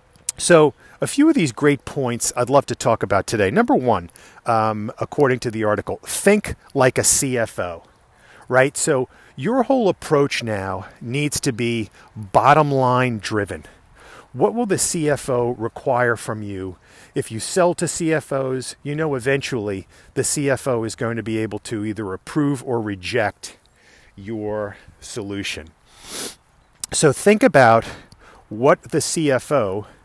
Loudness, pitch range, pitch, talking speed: -20 LUFS, 110-145 Hz, 125 Hz, 140 wpm